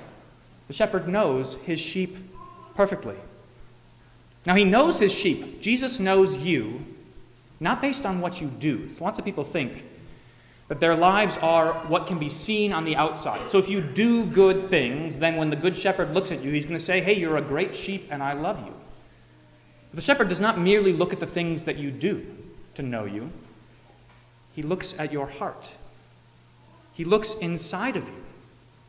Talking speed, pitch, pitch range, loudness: 185 wpm, 170 Hz, 145-195 Hz, -24 LUFS